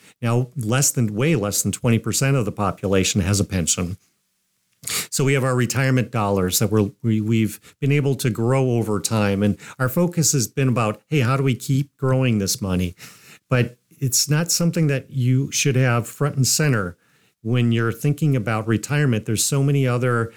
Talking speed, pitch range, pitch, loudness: 190 wpm, 105-135 Hz, 120 Hz, -20 LUFS